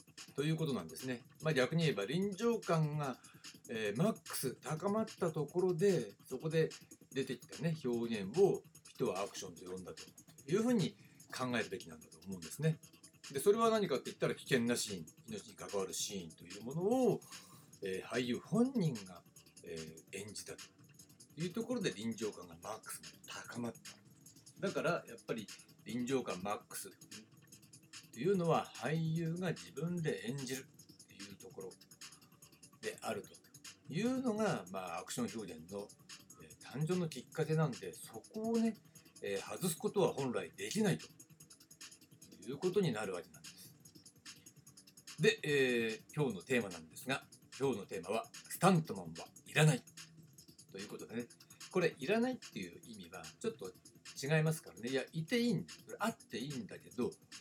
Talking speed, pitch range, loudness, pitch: 325 characters per minute, 135-180 Hz, -38 LUFS, 160 Hz